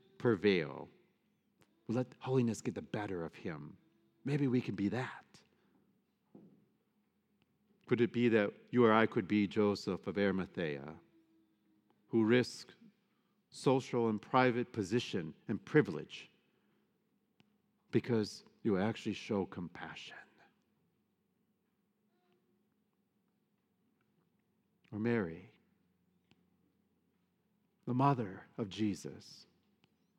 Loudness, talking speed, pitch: -35 LUFS, 90 wpm, 130 Hz